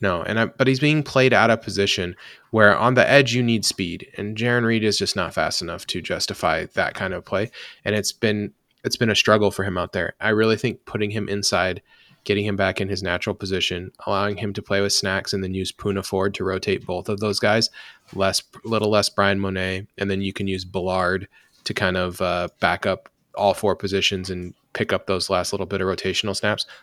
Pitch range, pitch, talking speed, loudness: 95-105 Hz, 100 Hz, 230 wpm, -22 LUFS